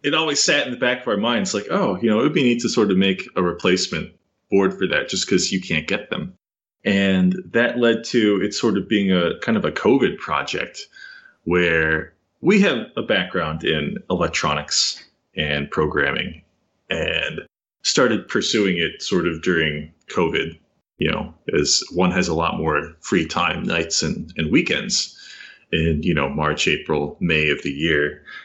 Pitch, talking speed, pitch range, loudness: 100 Hz, 185 wpm, 80-120 Hz, -20 LUFS